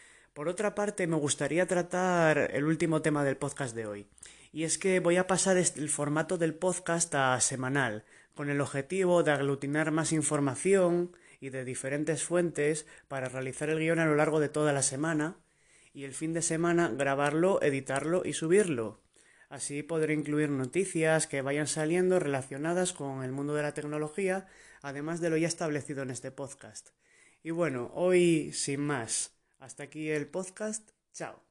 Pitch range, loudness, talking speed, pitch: 140-170 Hz, -30 LUFS, 170 wpm, 150 Hz